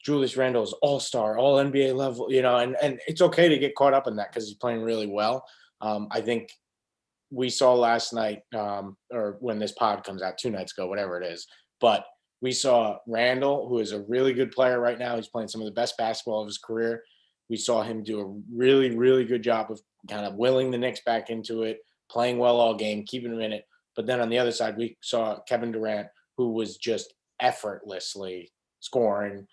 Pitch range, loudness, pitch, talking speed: 110-125 Hz, -26 LUFS, 115 Hz, 220 wpm